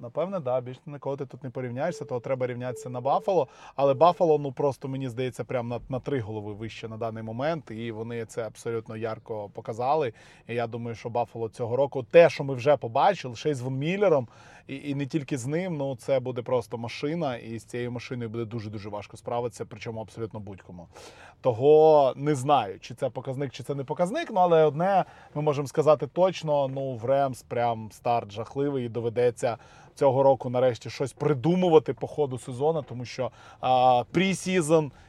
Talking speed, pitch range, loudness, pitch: 190 wpm, 120-145 Hz, -27 LUFS, 130 Hz